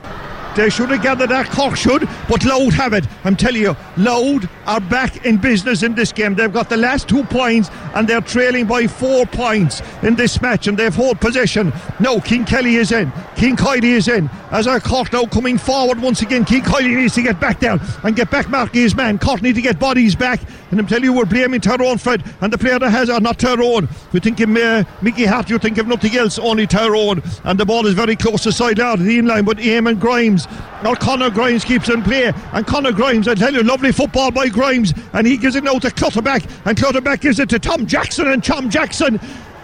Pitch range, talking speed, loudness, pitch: 220-255 Hz, 230 wpm, -15 LUFS, 235 Hz